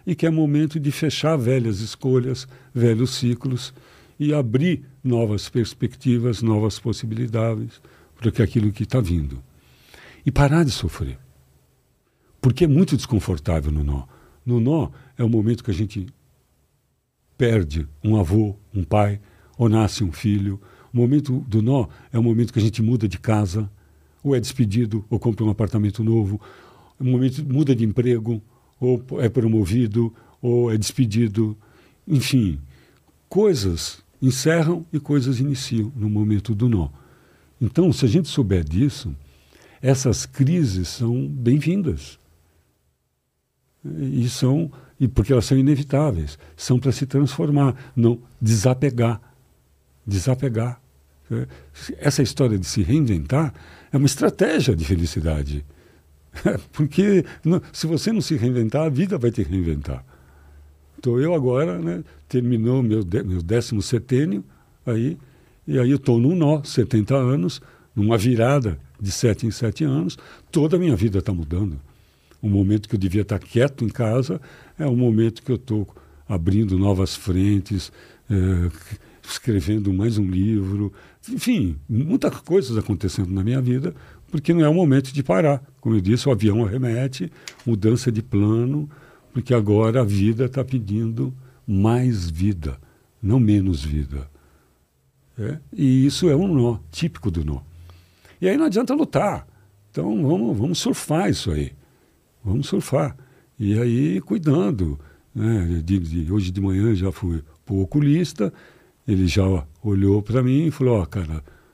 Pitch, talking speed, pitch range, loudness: 115 Hz, 145 wpm, 95-130 Hz, -21 LUFS